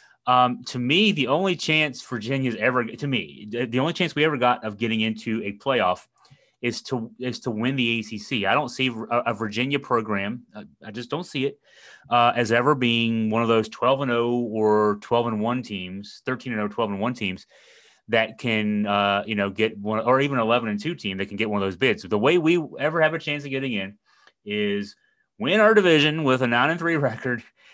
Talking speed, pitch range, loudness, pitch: 225 wpm, 110-140 Hz, -23 LUFS, 120 Hz